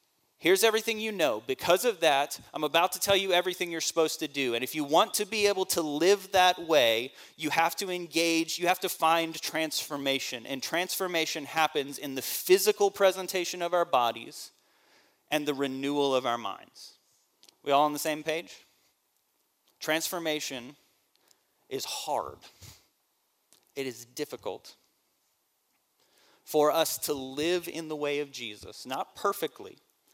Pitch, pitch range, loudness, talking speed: 160 Hz, 145-180 Hz, -28 LUFS, 150 wpm